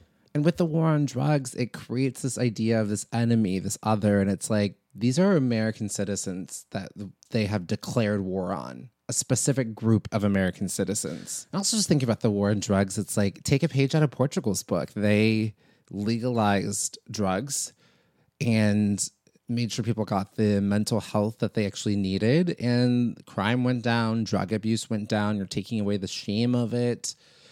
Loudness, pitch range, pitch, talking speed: -26 LUFS, 105-125 Hz, 110 Hz, 180 wpm